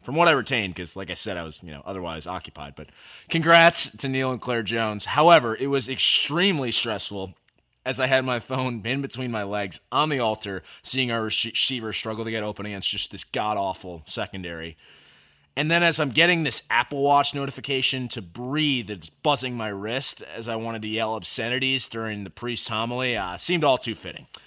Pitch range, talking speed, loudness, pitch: 100-130 Hz, 195 wpm, -23 LUFS, 115 Hz